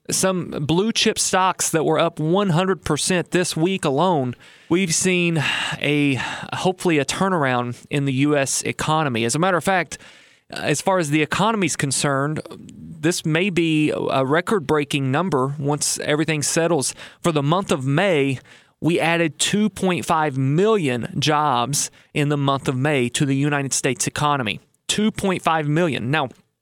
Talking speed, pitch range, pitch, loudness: 150 wpm, 145-180 Hz, 155 Hz, -20 LUFS